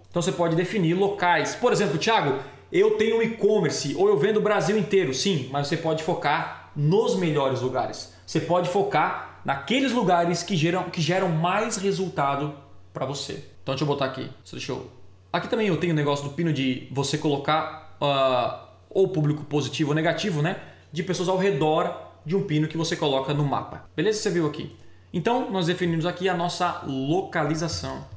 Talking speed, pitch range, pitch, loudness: 185 wpm, 145-190 Hz, 170 Hz, -24 LUFS